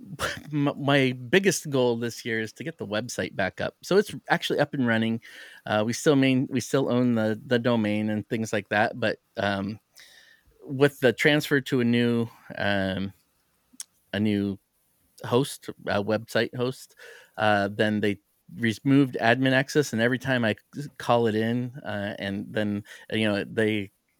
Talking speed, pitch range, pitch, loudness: 165 wpm, 105-135 Hz, 115 Hz, -26 LUFS